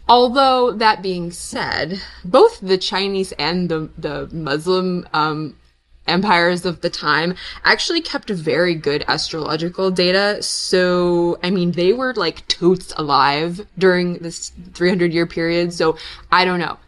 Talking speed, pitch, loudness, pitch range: 140 wpm, 180 Hz, -18 LUFS, 165-190 Hz